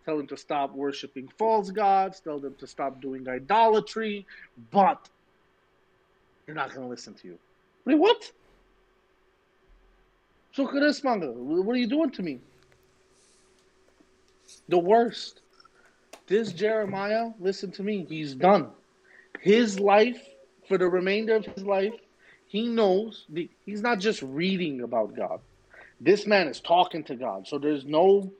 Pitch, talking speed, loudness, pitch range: 195 Hz, 135 wpm, -26 LUFS, 150-220 Hz